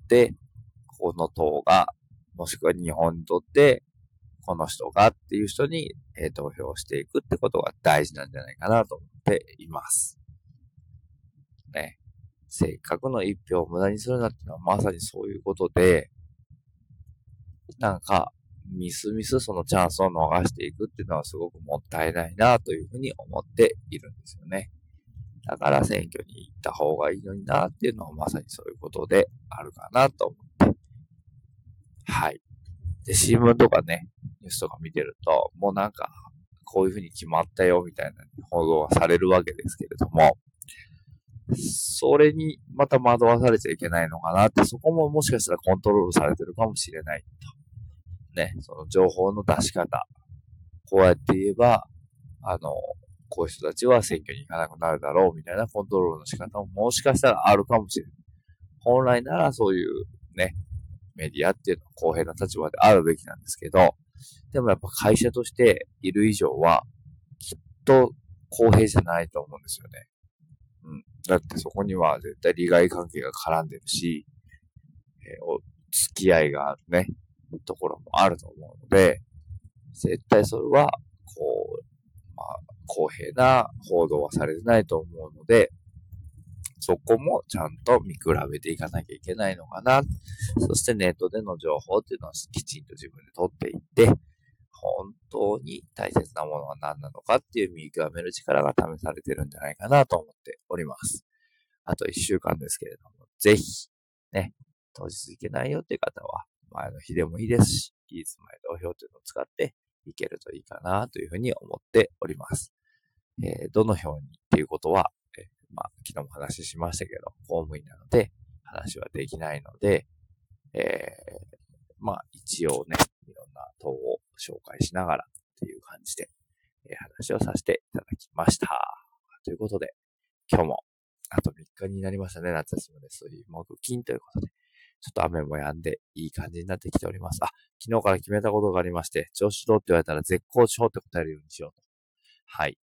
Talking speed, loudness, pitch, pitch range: 345 characters per minute, -25 LUFS, 105 Hz, 85-135 Hz